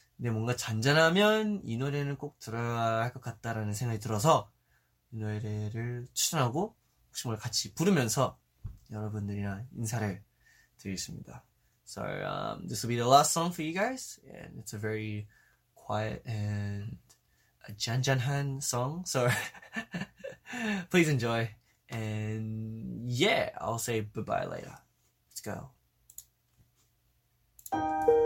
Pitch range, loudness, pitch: 110-145 Hz, -31 LUFS, 120 Hz